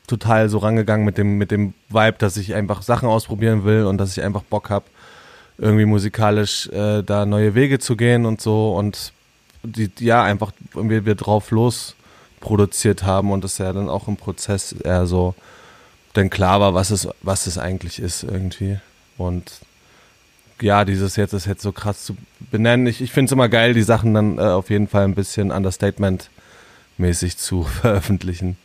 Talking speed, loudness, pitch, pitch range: 185 wpm, -19 LUFS, 105 Hz, 95-110 Hz